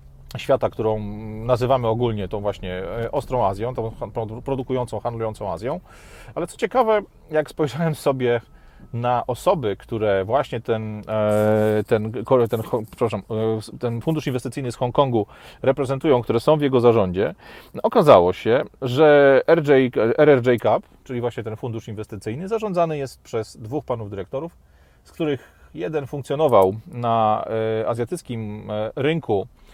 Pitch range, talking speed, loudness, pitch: 110-135 Hz, 125 wpm, -21 LUFS, 120 Hz